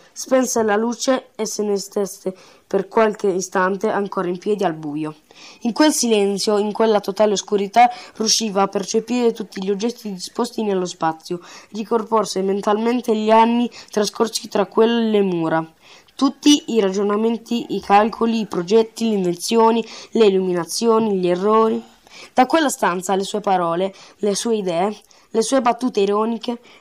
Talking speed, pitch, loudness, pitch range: 145 wpm, 210 Hz, -19 LUFS, 195-230 Hz